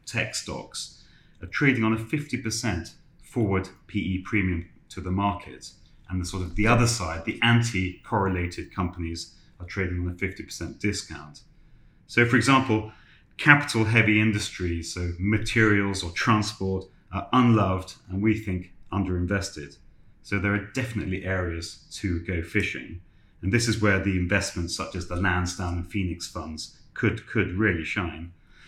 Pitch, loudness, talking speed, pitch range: 95 Hz, -26 LUFS, 150 wpm, 90-110 Hz